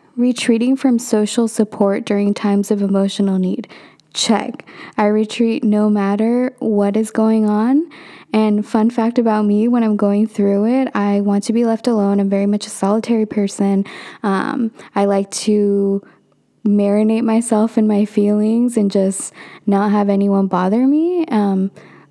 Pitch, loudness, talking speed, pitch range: 210 Hz, -16 LUFS, 155 wpm, 200-230 Hz